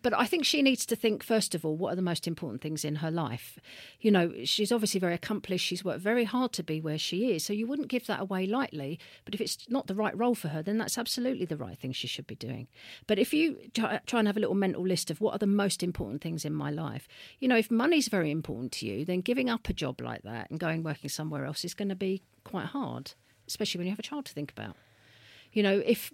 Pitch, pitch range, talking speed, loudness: 185 Hz, 155-225 Hz, 270 wpm, -31 LUFS